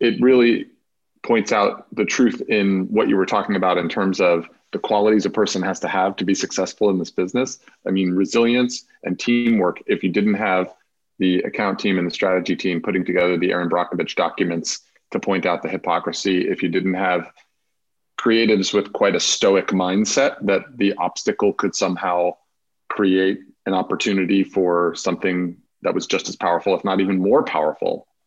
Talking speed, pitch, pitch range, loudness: 180 wpm, 95 Hz, 90-105 Hz, -20 LUFS